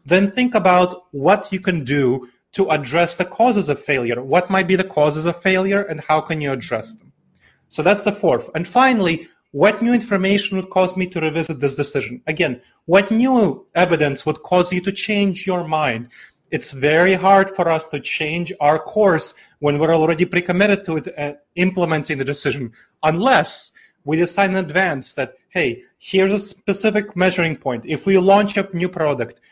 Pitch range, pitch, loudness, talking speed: 150-195 Hz, 175 Hz, -18 LUFS, 185 wpm